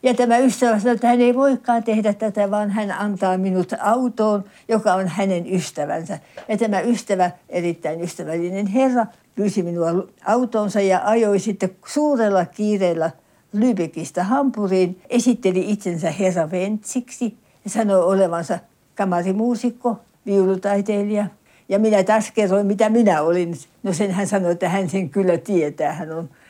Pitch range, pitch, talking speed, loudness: 185-225 Hz, 200 Hz, 140 wpm, -20 LUFS